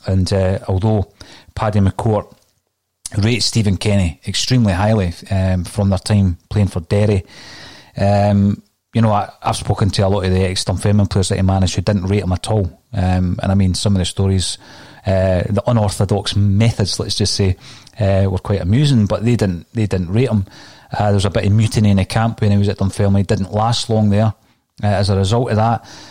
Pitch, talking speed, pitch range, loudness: 100 Hz, 210 wpm, 95-110 Hz, -16 LUFS